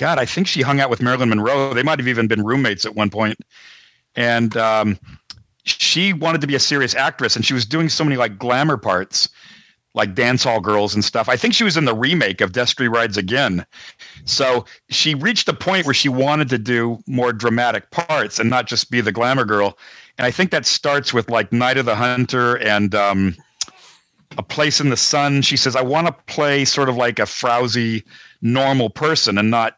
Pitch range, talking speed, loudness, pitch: 115-140 Hz, 210 wpm, -17 LUFS, 125 Hz